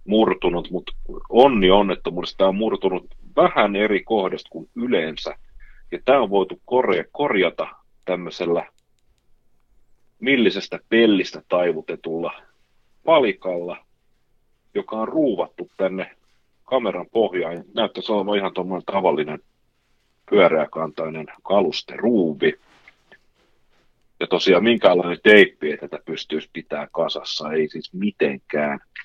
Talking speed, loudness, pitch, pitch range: 100 wpm, -21 LUFS, 95 Hz, 80-110 Hz